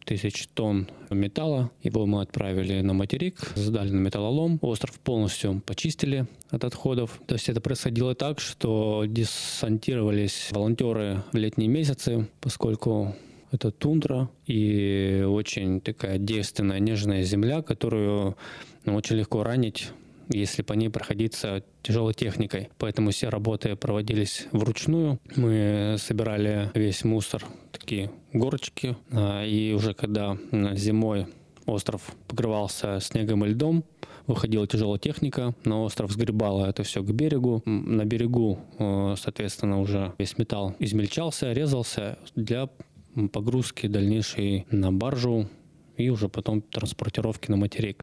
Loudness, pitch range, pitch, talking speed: -27 LUFS, 105-125 Hz, 110 Hz, 120 wpm